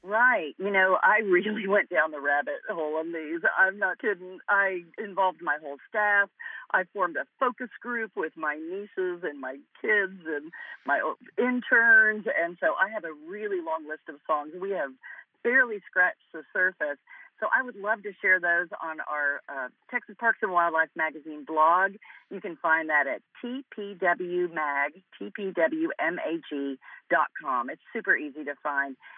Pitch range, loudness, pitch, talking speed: 160-235 Hz, -27 LUFS, 190 Hz, 160 wpm